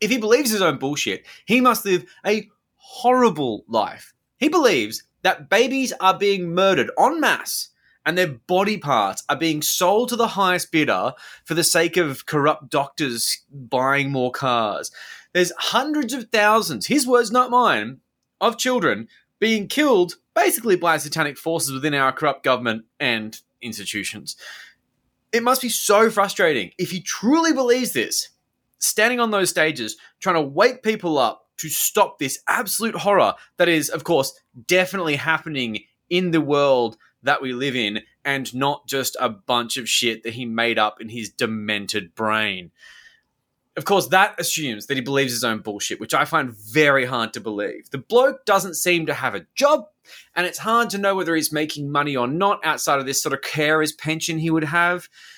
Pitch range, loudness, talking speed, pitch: 130-205 Hz, -20 LUFS, 175 wpm, 160 Hz